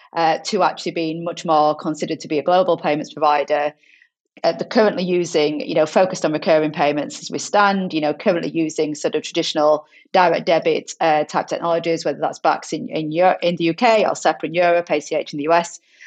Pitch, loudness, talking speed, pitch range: 165 Hz, -19 LUFS, 205 wpm, 155-180 Hz